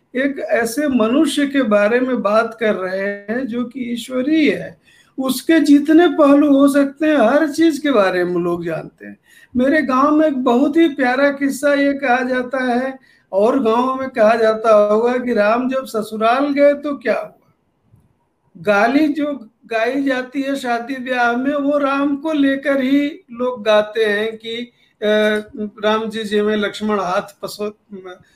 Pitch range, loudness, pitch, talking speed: 215-280 Hz, -16 LUFS, 250 Hz, 165 wpm